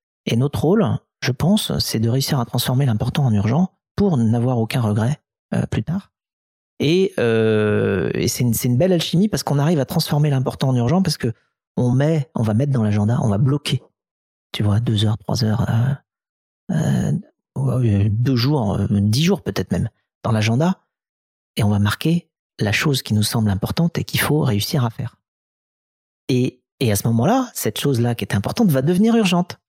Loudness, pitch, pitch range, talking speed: -19 LUFS, 125 Hz, 110-150 Hz, 190 wpm